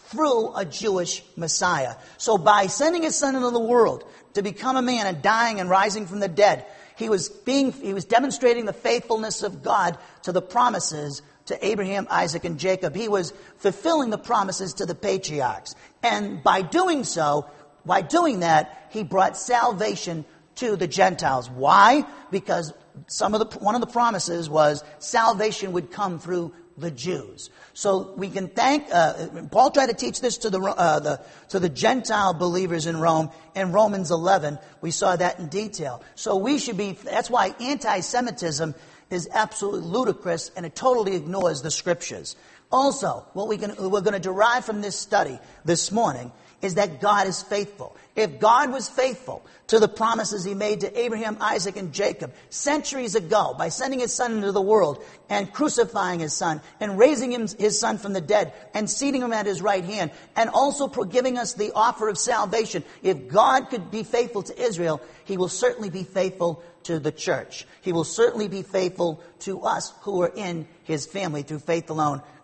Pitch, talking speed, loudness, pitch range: 200 Hz, 180 wpm, -23 LUFS, 175-225 Hz